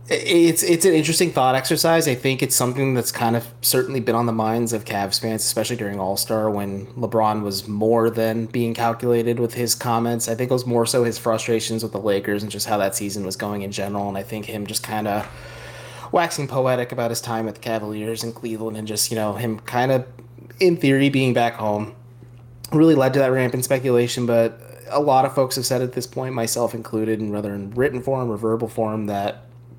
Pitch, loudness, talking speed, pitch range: 115 Hz, -21 LUFS, 220 wpm, 110-125 Hz